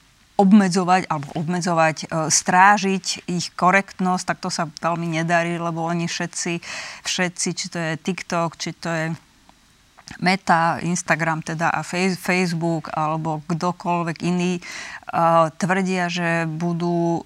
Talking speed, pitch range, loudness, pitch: 115 wpm, 165-180 Hz, -21 LUFS, 170 Hz